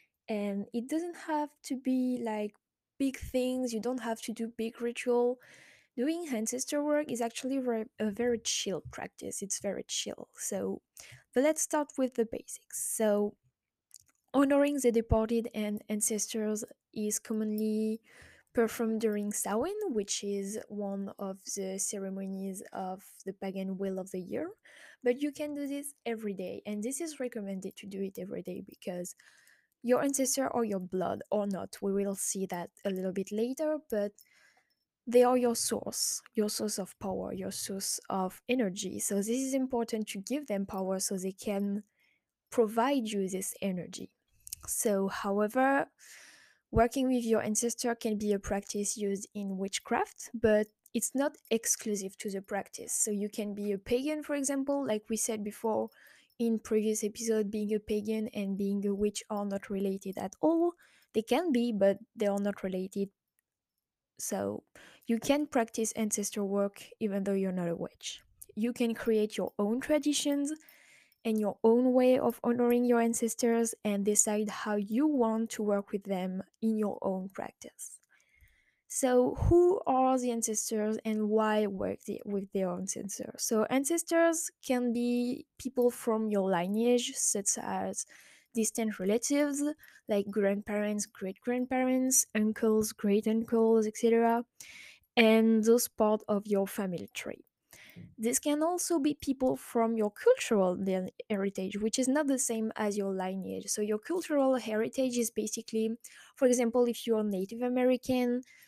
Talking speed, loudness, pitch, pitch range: 155 wpm, -32 LUFS, 220 Hz, 205-250 Hz